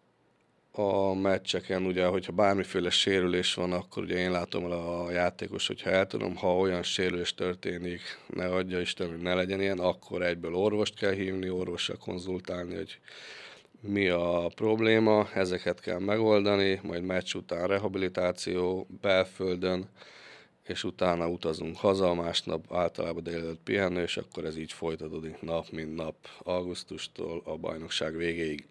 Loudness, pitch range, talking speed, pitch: -30 LUFS, 85-95 Hz, 140 wpm, 90 Hz